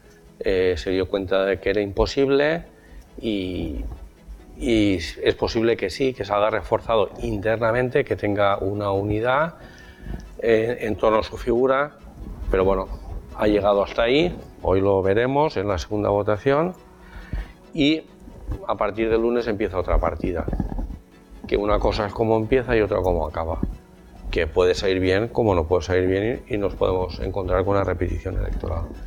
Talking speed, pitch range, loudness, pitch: 160 wpm, 95-115 Hz, -22 LUFS, 100 Hz